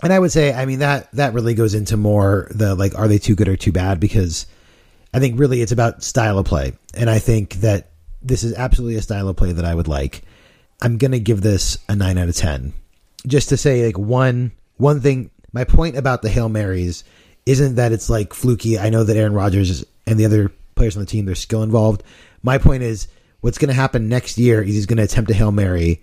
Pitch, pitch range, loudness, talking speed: 110 Hz, 95-120 Hz, -18 LUFS, 240 wpm